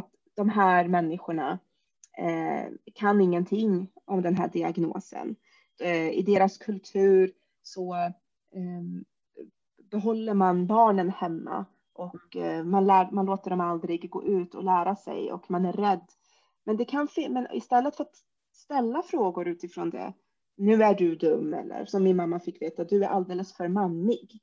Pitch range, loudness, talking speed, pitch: 175-210 Hz, -27 LUFS, 155 wpm, 190 Hz